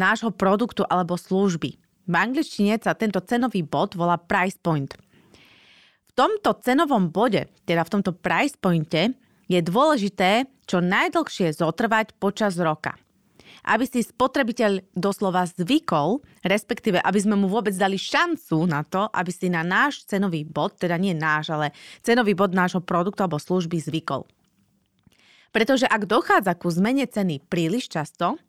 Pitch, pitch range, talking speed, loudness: 195 Hz, 175-225 Hz, 145 wpm, -23 LUFS